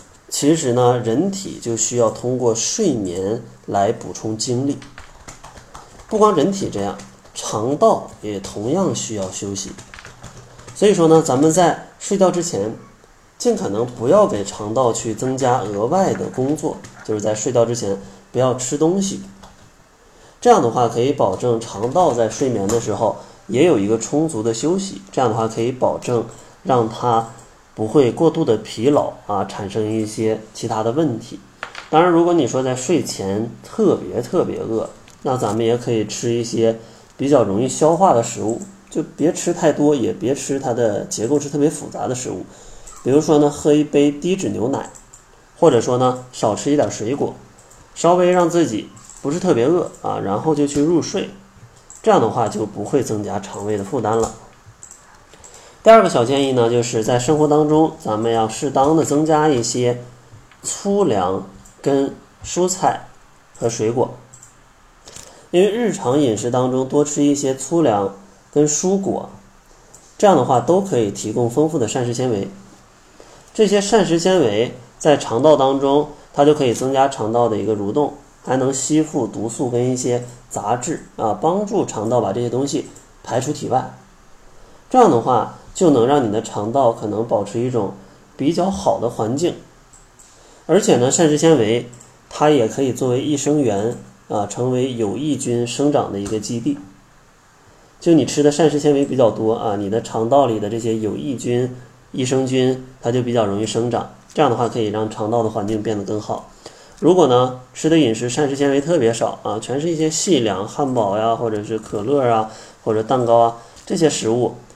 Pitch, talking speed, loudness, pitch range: 125 Hz, 255 characters per minute, -18 LUFS, 115-150 Hz